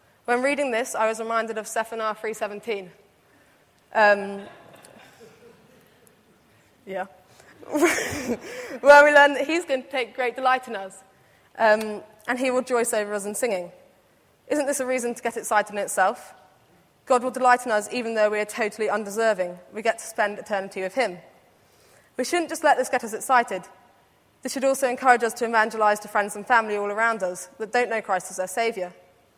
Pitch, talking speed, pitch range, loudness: 225 Hz, 180 wpm, 205-255 Hz, -23 LUFS